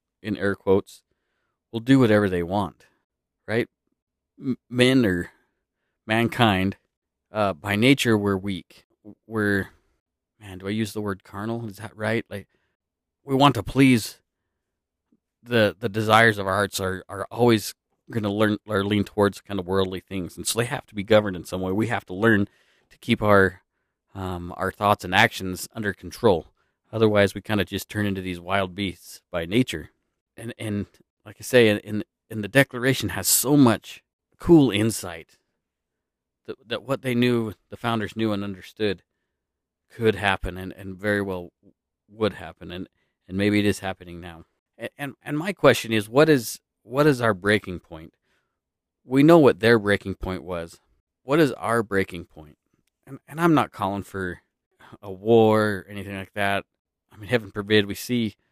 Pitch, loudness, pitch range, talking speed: 100 Hz, -23 LUFS, 95-115 Hz, 175 wpm